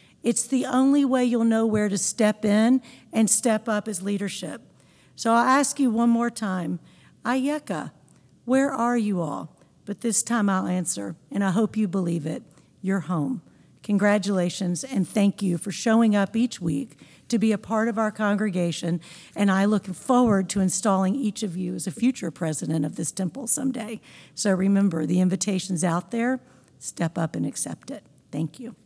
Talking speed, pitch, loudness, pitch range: 180 wpm, 205 Hz, -24 LUFS, 180-230 Hz